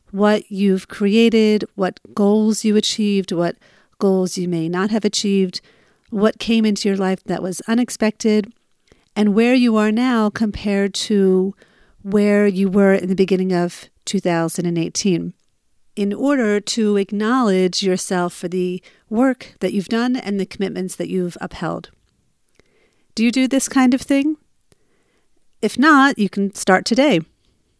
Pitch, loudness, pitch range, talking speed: 200 Hz, -18 LUFS, 185-220 Hz, 145 wpm